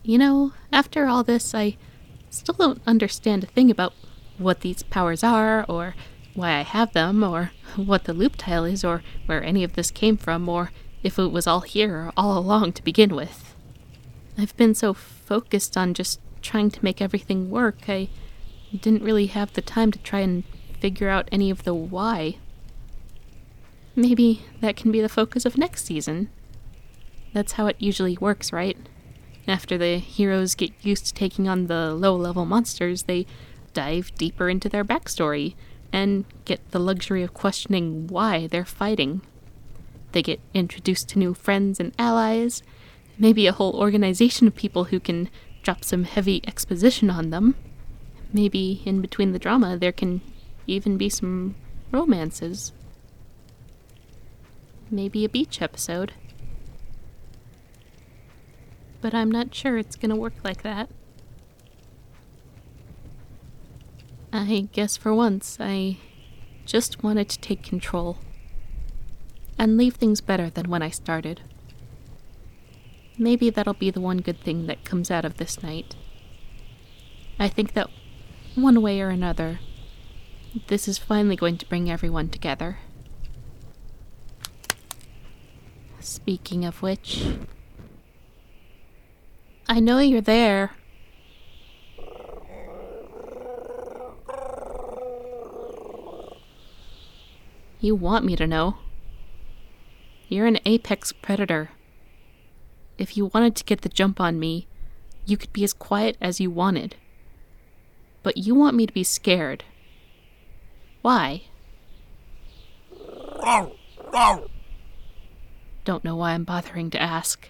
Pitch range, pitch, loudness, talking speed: 175-220 Hz, 195 Hz, -23 LUFS, 130 wpm